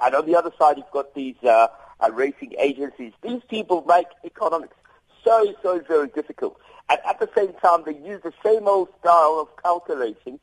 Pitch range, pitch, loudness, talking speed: 150-225 Hz, 175 Hz, -21 LUFS, 190 wpm